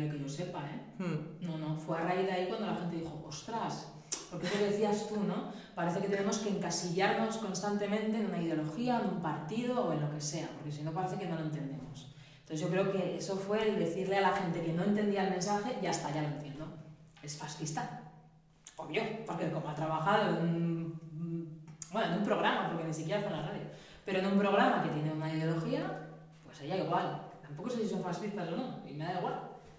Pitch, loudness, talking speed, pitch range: 175 Hz, -35 LUFS, 220 wpm, 155-200 Hz